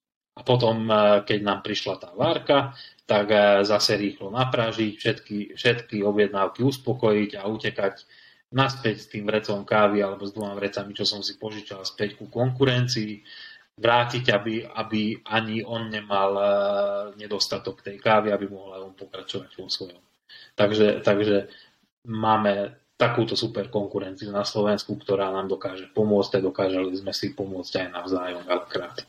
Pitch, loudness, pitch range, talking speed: 105 Hz, -24 LUFS, 100-110 Hz, 140 wpm